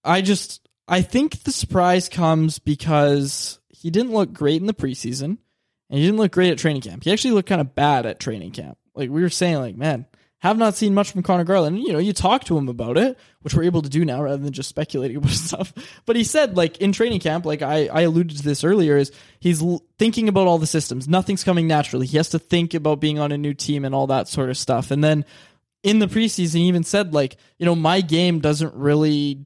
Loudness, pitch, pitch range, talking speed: -20 LUFS, 165 Hz, 145-190 Hz, 245 wpm